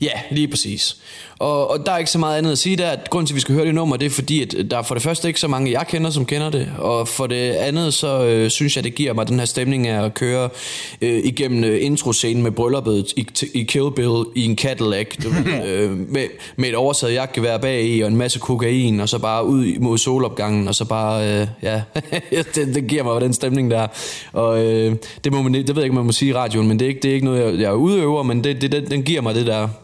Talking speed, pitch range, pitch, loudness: 270 wpm, 115-140 Hz, 125 Hz, -19 LUFS